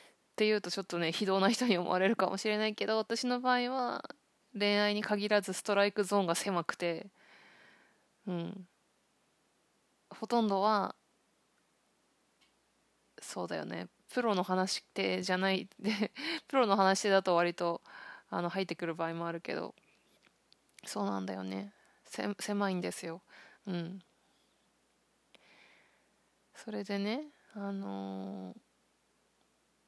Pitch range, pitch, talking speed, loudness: 175-215 Hz, 195 Hz, 235 characters per minute, -33 LUFS